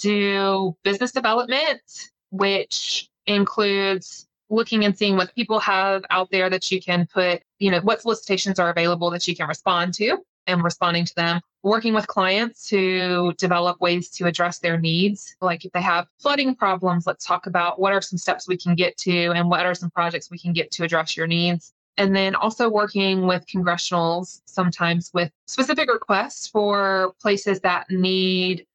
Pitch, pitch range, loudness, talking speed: 185 Hz, 175-200 Hz, -21 LUFS, 175 wpm